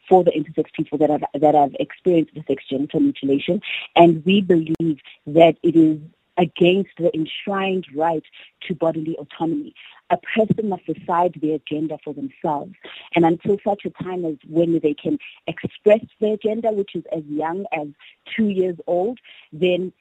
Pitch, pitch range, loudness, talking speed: 165 Hz, 155-185 Hz, -20 LUFS, 165 wpm